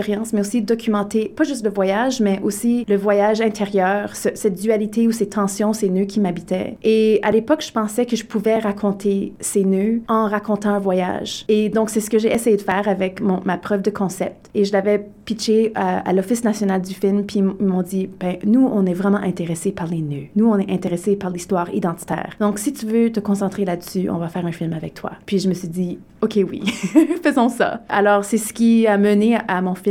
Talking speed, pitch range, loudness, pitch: 230 wpm, 190-220 Hz, -19 LUFS, 205 Hz